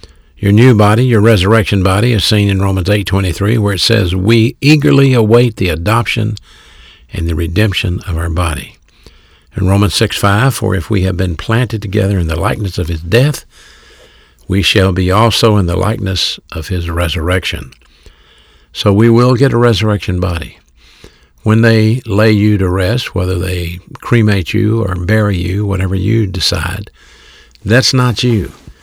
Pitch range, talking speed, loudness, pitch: 90-110 Hz, 160 wpm, -12 LUFS, 100 Hz